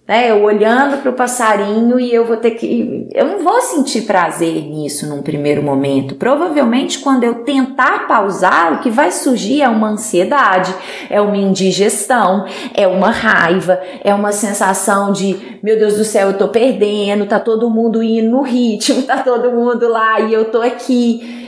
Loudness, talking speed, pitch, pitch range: -13 LUFS, 175 wpm, 220 Hz, 200-245 Hz